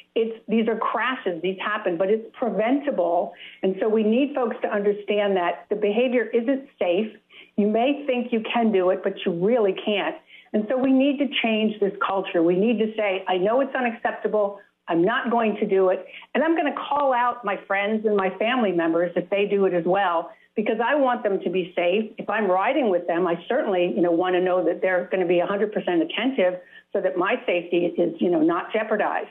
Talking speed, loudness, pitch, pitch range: 220 wpm, -23 LUFS, 210 Hz, 185-235 Hz